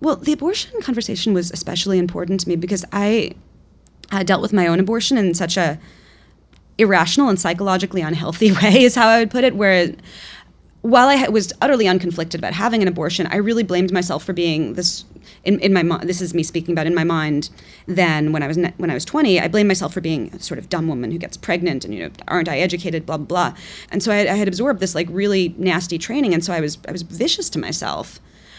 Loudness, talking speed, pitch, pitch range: -18 LUFS, 230 wpm, 185 Hz, 170-210 Hz